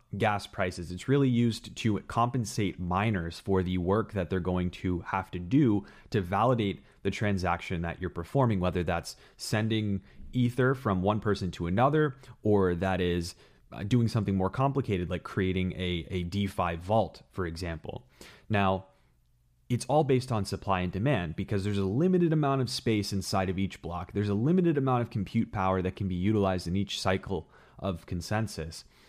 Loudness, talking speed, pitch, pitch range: -30 LUFS, 175 wpm, 100 Hz, 90-115 Hz